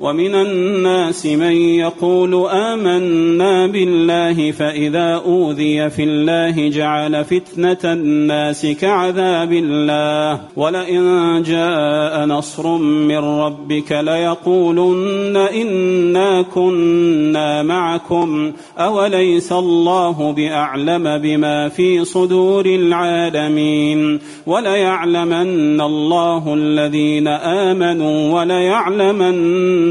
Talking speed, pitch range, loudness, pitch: 70 wpm, 150-180 Hz, -15 LUFS, 170 Hz